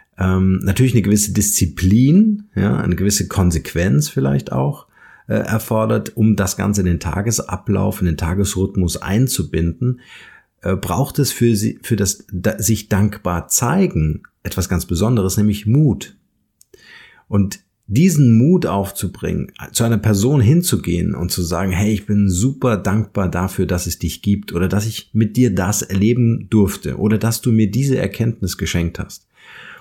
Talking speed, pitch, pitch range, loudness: 150 wpm, 105 Hz, 95-115 Hz, -17 LUFS